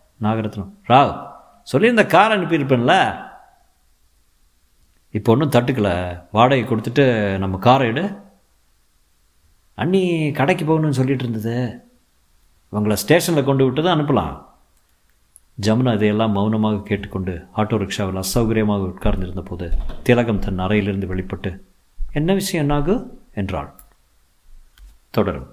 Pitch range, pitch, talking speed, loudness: 95-135 Hz, 105 Hz, 100 wpm, -19 LUFS